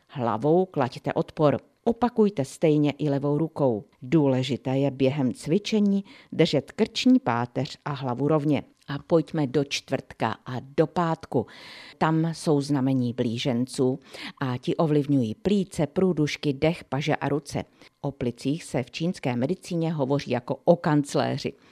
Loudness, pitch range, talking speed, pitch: -25 LUFS, 130-165 Hz, 135 wpm, 145 Hz